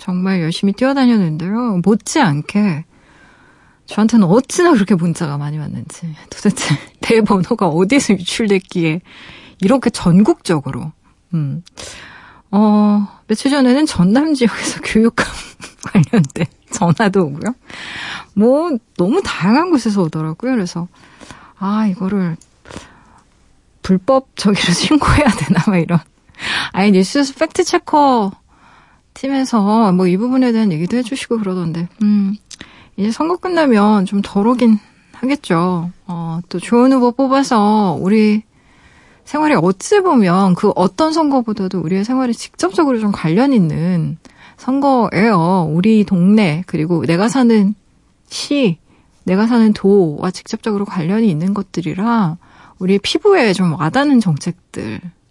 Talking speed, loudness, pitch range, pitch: 275 characters per minute, -15 LUFS, 180-245 Hz, 205 Hz